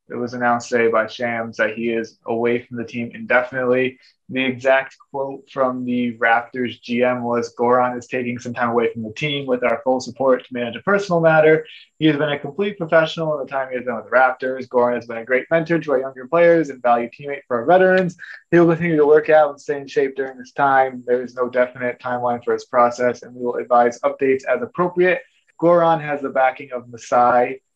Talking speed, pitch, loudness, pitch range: 225 wpm, 130 Hz, -19 LUFS, 120-150 Hz